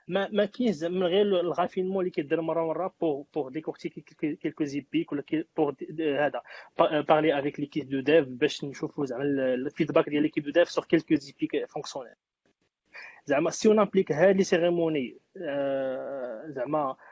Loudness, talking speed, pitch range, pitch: -27 LUFS, 135 wpm, 145-175 Hz, 160 Hz